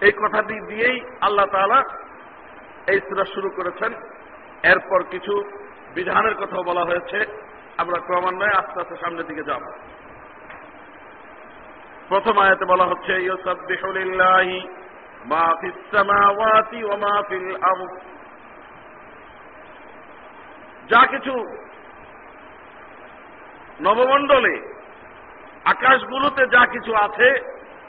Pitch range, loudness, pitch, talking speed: 185-220 Hz, -19 LUFS, 195 Hz, 70 wpm